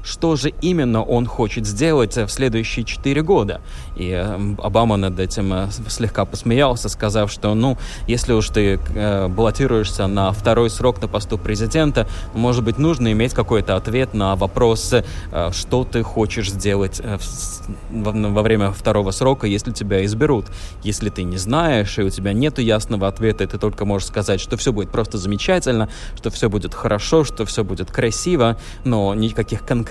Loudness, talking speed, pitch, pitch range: -19 LUFS, 155 wpm, 110 Hz, 100-120 Hz